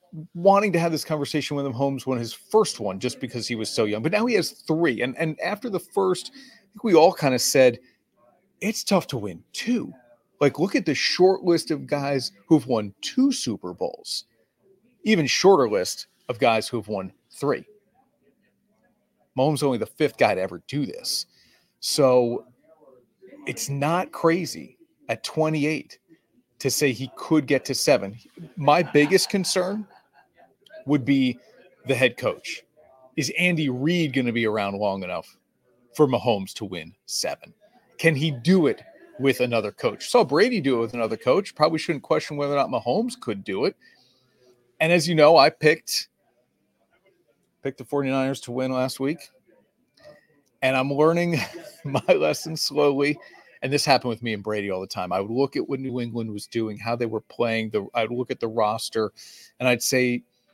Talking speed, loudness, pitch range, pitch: 180 wpm, -23 LUFS, 120-170 Hz, 140 Hz